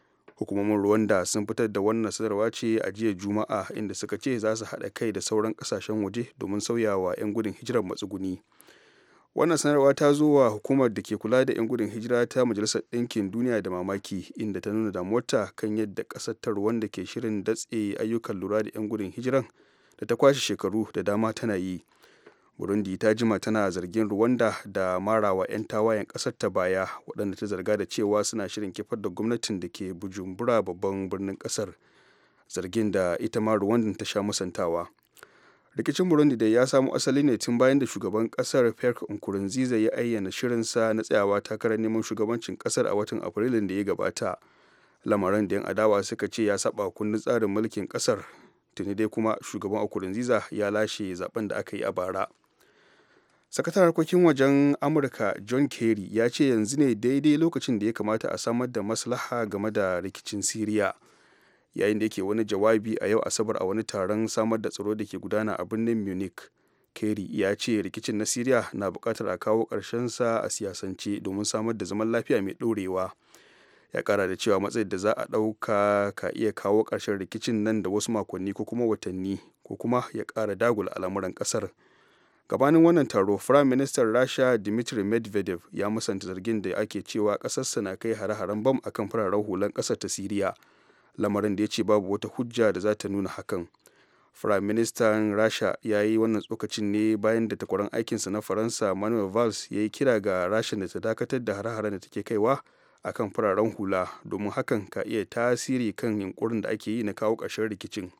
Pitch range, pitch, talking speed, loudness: 100-115 Hz, 110 Hz, 175 wpm, -27 LUFS